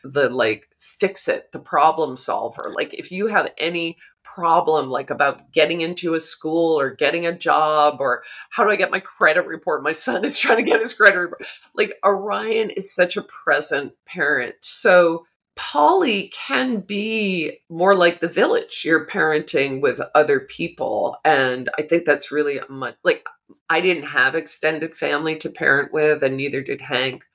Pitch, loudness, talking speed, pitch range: 165 Hz, -19 LUFS, 175 wpm, 150-195 Hz